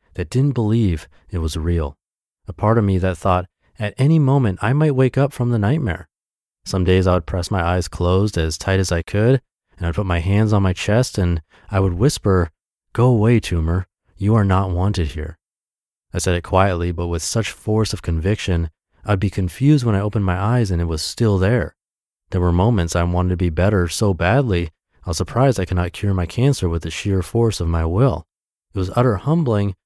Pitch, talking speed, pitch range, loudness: 95 Hz, 215 wpm, 85-110 Hz, -19 LUFS